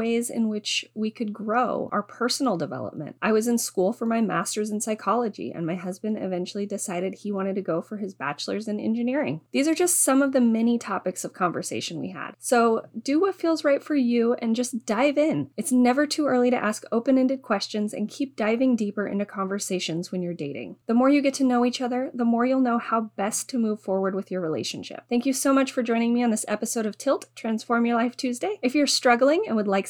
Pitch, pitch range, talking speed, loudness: 230 Hz, 205-255 Hz, 230 wpm, -25 LUFS